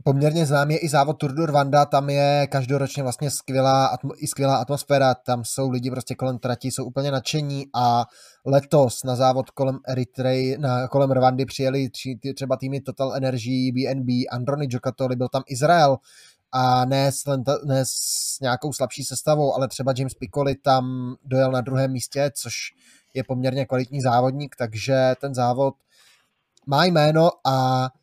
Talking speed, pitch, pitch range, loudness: 160 wpm, 135 Hz, 130-140 Hz, -22 LUFS